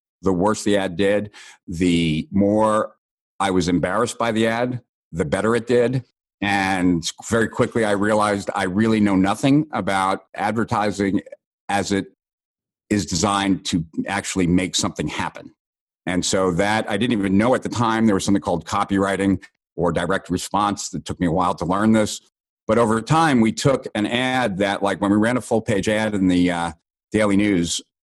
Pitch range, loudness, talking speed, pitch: 95-110 Hz, -20 LUFS, 180 wpm, 100 Hz